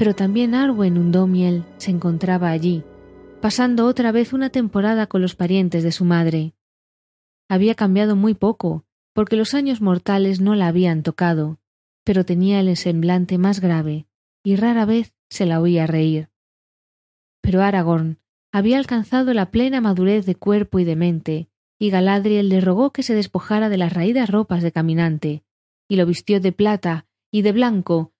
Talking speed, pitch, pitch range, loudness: 160 wpm, 185 Hz, 170-210 Hz, -19 LUFS